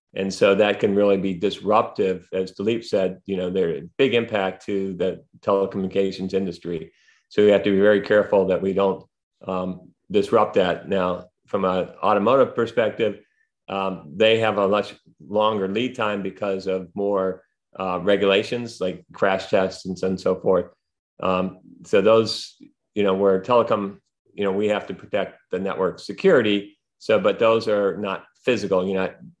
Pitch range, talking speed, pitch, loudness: 95-105 Hz, 170 wpm, 100 Hz, -22 LUFS